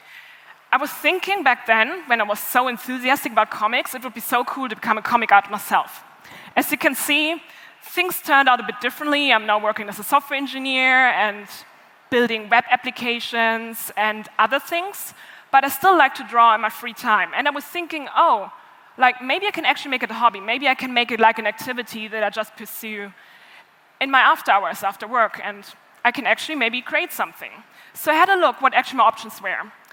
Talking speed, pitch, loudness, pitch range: 215 wpm, 245 Hz, -19 LUFS, 220-280 Hz